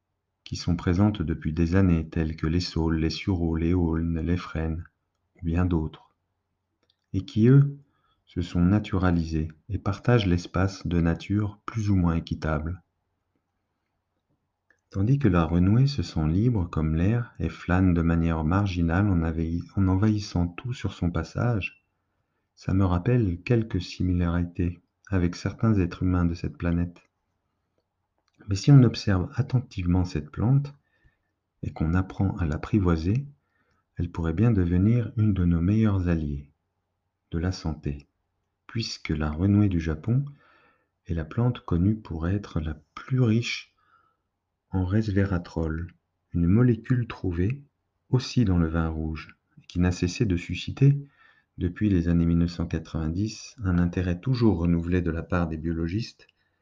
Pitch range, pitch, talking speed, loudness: 85-105 Hz, 90 Hz, 140 wpm, -26 LUFS